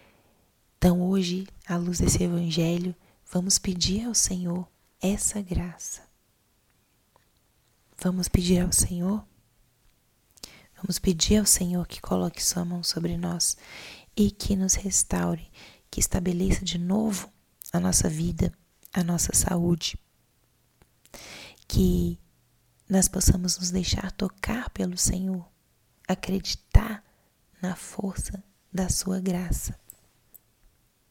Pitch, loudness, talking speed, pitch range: 180 Hz, -26 LUFS, 105 wpm, 125-190 Hz